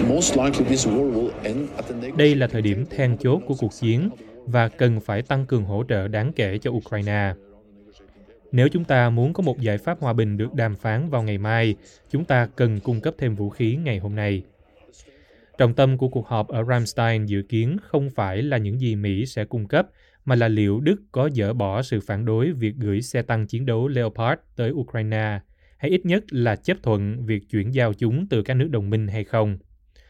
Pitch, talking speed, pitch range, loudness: 115 Hz, 200 wpm, 105-130 Hz, -23 LUFS